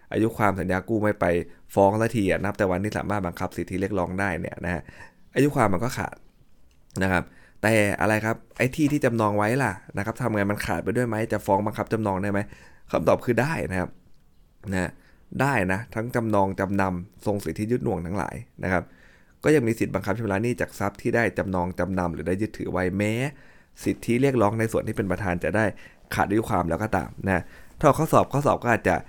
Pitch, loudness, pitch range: 100 Hz, -25 LUFS, 90-115 Hz